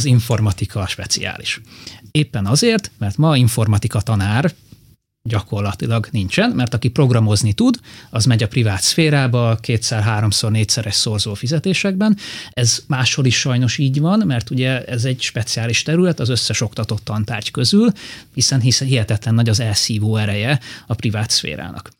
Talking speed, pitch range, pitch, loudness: 140 wpm, 110-130 Hz, 115 Hz, -17 LUFS